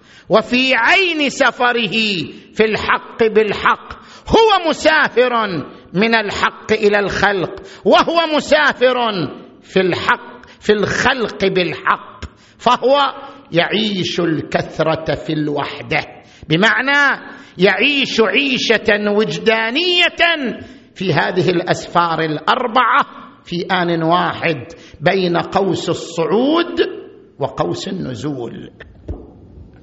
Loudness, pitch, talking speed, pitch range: -15 LUFS, 210 Hz, 80 wpm, 175-255 Hz